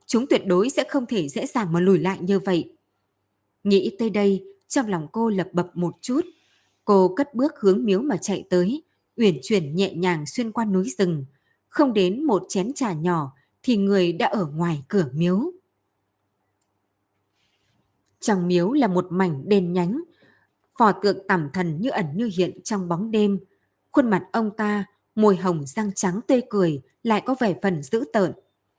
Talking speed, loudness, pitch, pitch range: 180 wpm, -23 LUFS, 190 Hz, 170-220 Hz